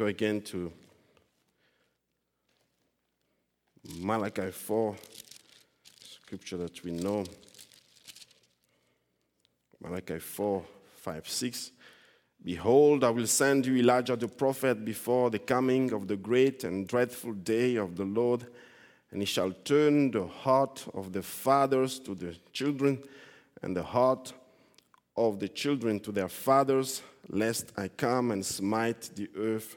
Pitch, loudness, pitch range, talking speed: 115 Hz, -30 LUFS, 100-130 Hz, 120 wpm